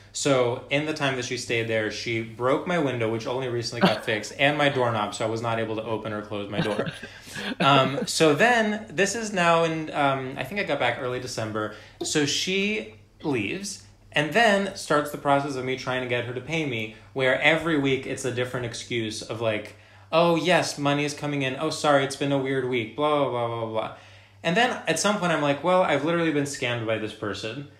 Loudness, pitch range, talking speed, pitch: -25 LUFS, 115-150 Hz, 225 wpm, 130 Hz